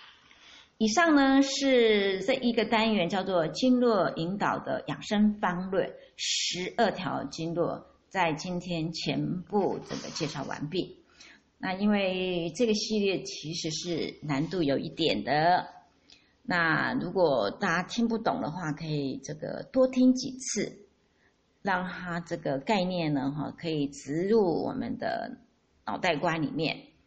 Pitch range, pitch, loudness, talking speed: 165-230 Hz, 185 Hz, -28 LUFS, 200 characters per minute